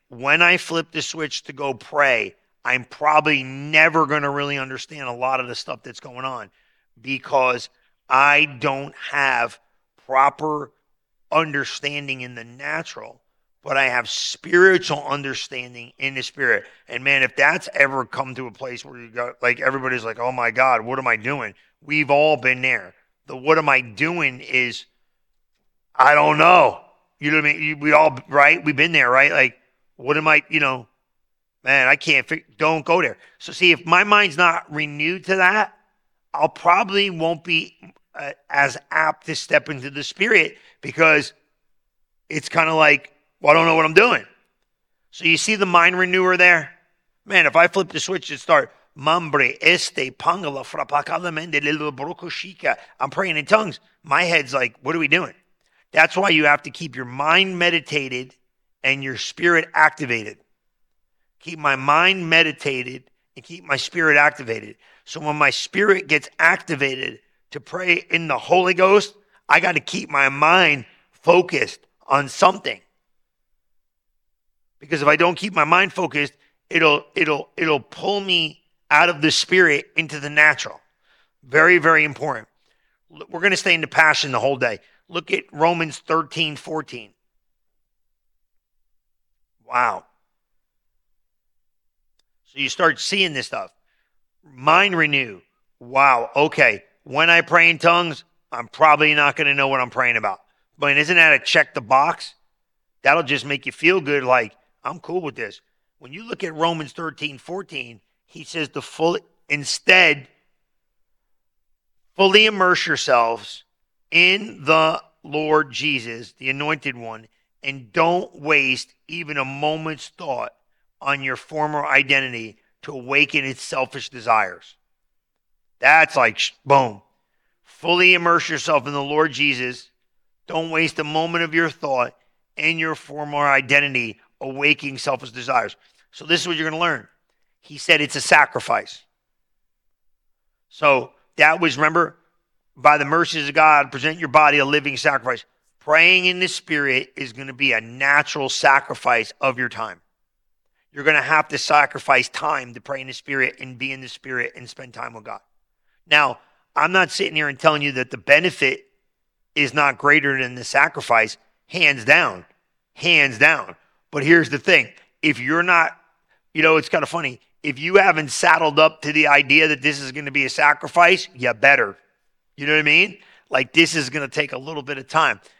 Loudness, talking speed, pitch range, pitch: -17 LUFS, 165 wpm, 135-165 Hz, 150 Hz